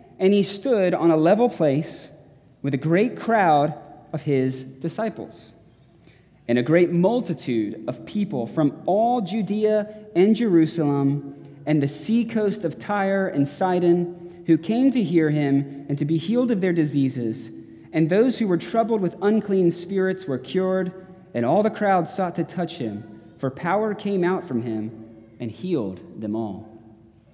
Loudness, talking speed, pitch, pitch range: -22 LUFS, 160 wpm, 170 Hz, 140-195 Hz